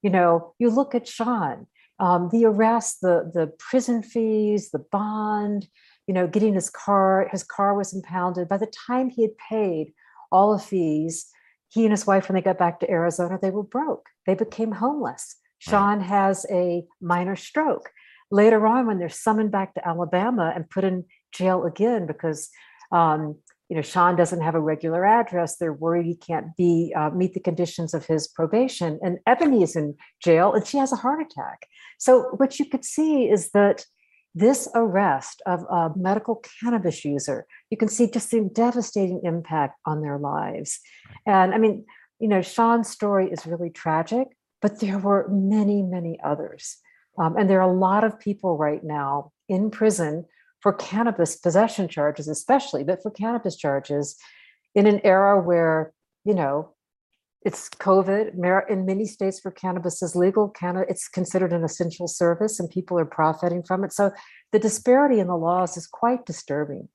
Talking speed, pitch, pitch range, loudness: 175 wpm, 190 Hz, 170-220 Hz, -23 LUFS